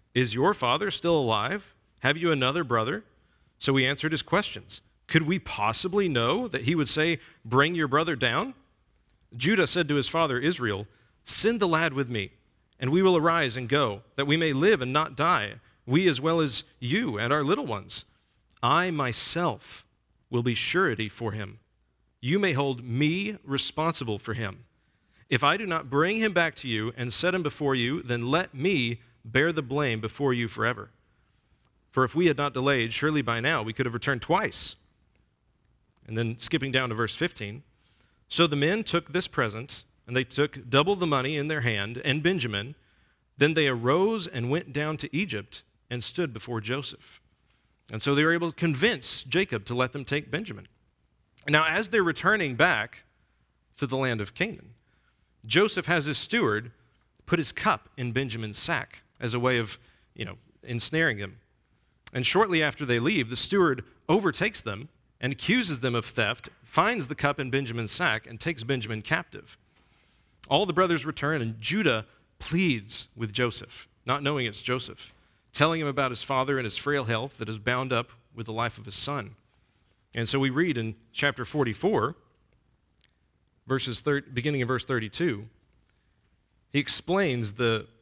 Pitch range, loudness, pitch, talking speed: 115-155 Hz, -27 LUFS, 130 Hz, 175 wpm